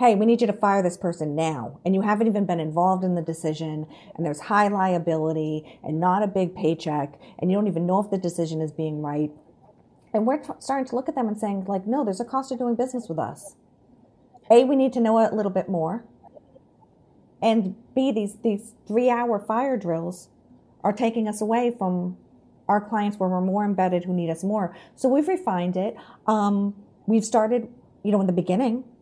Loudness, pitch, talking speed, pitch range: -24 LUFS, 200 Hz, 215 wpm, 175-230 Hz